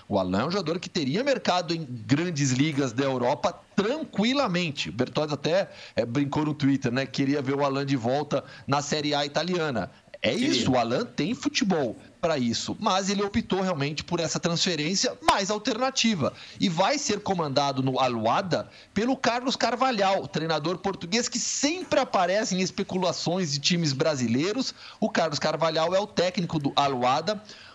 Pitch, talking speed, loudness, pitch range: 170 Hz, 165 wpm, -26 LUFS, 140-210 Hz